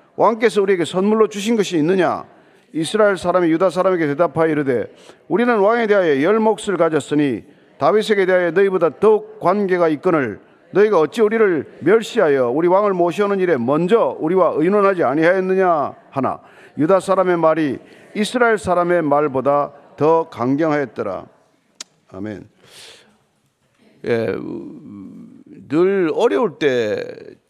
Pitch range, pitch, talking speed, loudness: 165-215 Hz, 190 Hz, 310 characters per minute, -17 LUFS